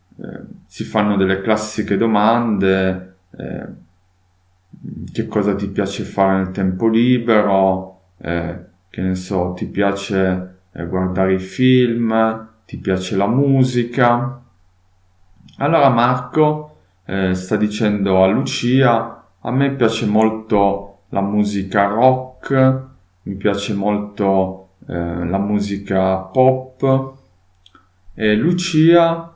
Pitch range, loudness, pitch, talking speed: 95-120 Hz, -17 LUFS, 100 Hz, 110 wpm